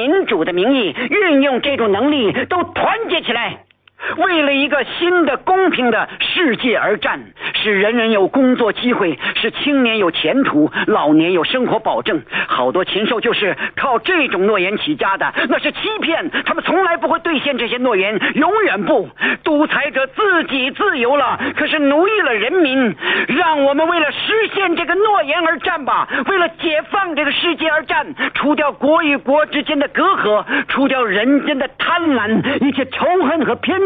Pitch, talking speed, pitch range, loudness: 305 Hz, 255 characters per minute, 275-340 Hz, -15 LUFS